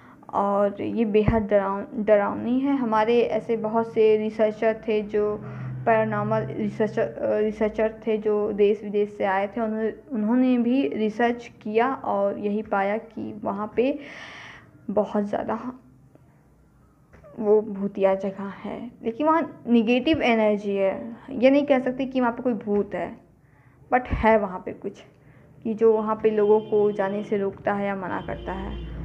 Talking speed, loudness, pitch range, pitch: 155 wpm, -24 LUFS, 205-235 Hz, 215 Hz